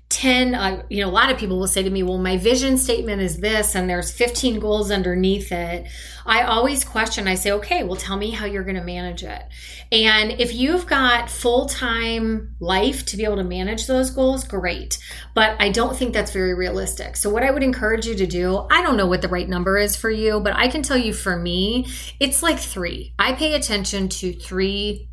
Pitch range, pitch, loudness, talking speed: 190-240 Hz, 210 Hz, -20 LUFS, 225 wpm